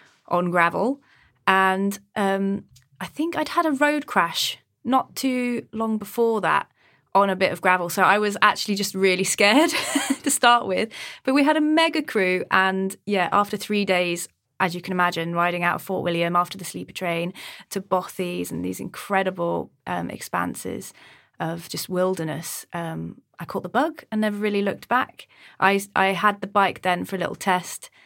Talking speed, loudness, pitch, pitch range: 180 wpm, -23 LUFS, 195 Hz, 180-225 Hz